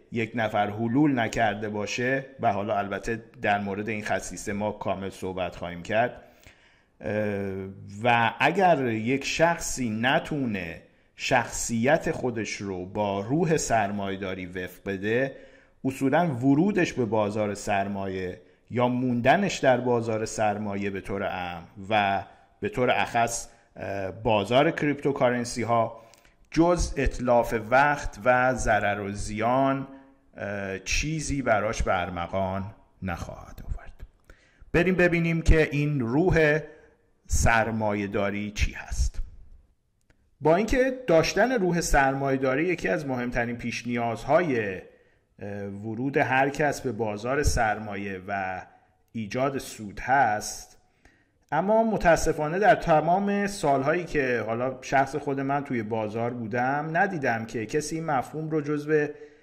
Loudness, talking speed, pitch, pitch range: -26 LUFS, 110 wpm, 115 Hz, 100-145 Hz